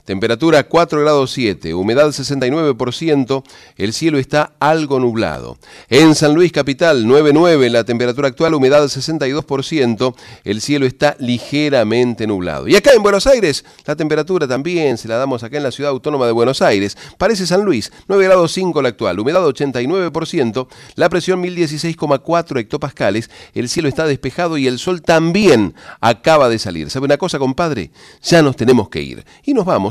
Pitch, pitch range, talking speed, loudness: 145 Hz, 125-165 Hz, 165 wpm, -14 LUFS